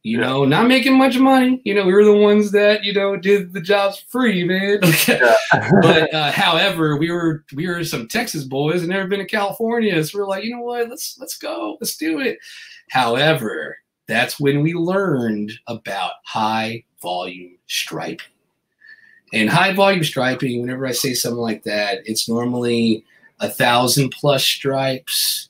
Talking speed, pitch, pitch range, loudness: 170 wpm, 175 Hz, 130-210 Hz, -17 LUFS